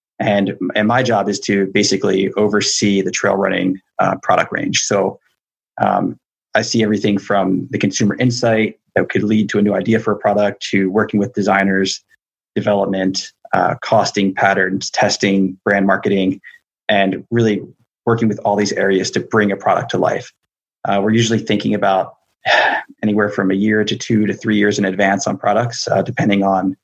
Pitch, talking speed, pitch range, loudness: 100 Hz, 175 wpm, 95-105 Hz, -16 LUFS